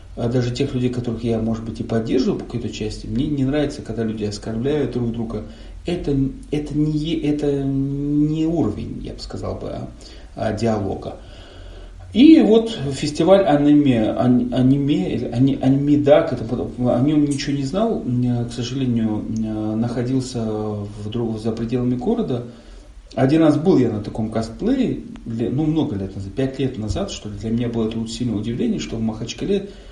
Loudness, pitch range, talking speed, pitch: -20 LUFS, 110-145 Hz, 150 wpm, 120 Hz